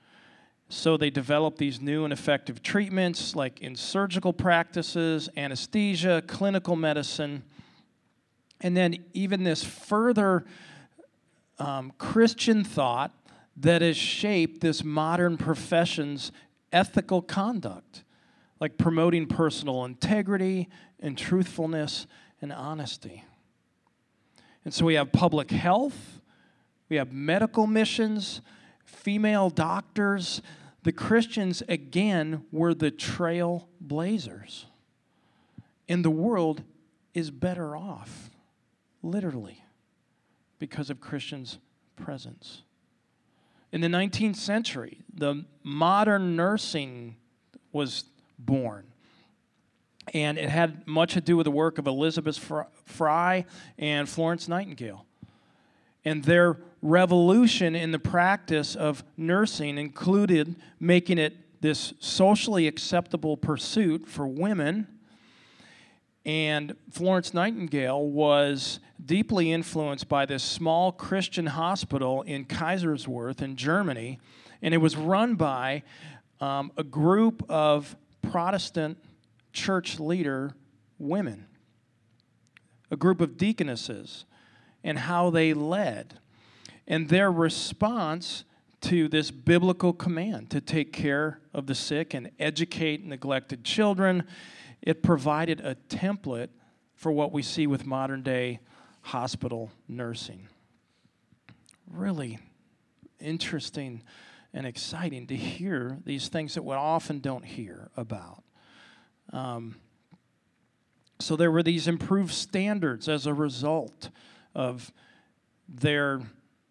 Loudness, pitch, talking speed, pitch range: -27 LUFS, 160 Hz, 105 wpm, 145-180 Hz